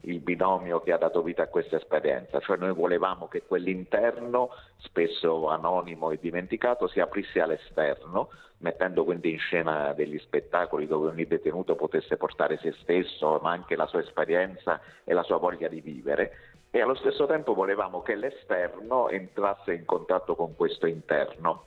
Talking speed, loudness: 160 wpm, -28 LUFS